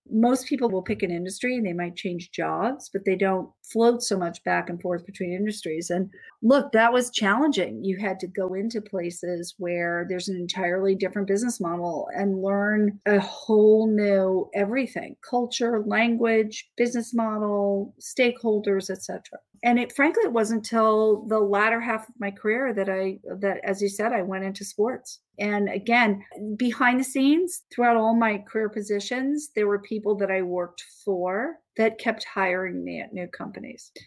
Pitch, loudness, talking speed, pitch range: 210 Hz, -25 LUFS, 175 wpm, 190-230 Hz